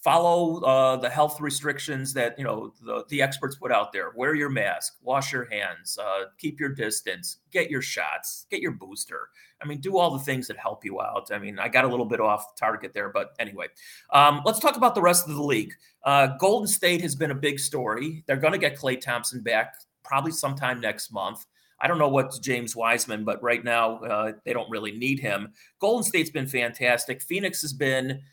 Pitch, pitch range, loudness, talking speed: 140 Hz, 120-155 Hz, -25 LUFS, 215 wpm